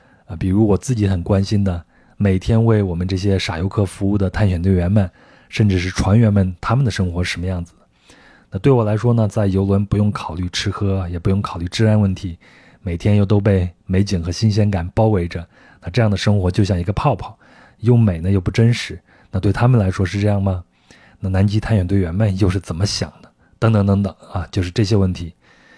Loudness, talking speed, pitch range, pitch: -18 LUFS, 320 characters per minute, 90-105 Hz, 100 Hz